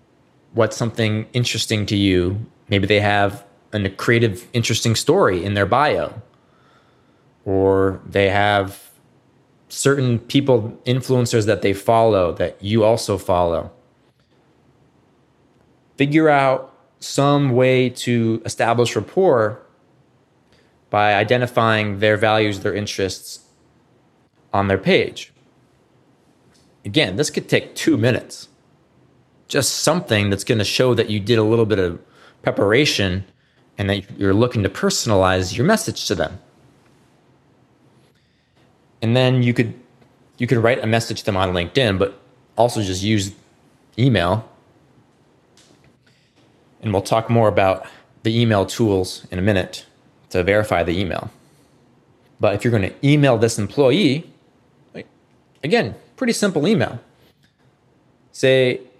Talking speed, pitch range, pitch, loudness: 120 wpm, 100-130 Hz, 115 Hz, -18 LUFS